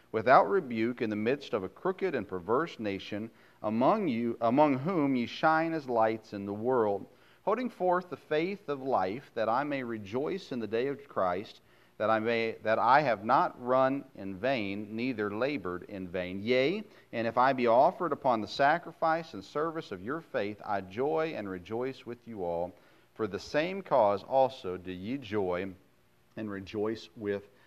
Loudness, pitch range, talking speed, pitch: -31 LUFS, 100-140 Hz, 180 wpm, 115 Hz